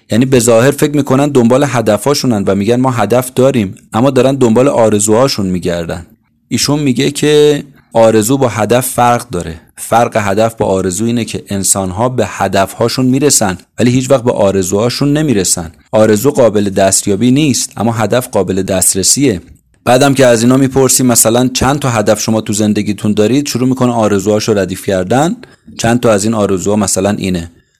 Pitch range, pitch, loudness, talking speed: 105-130 Hz, 115 Hz, -11 LUFS, 165 wpm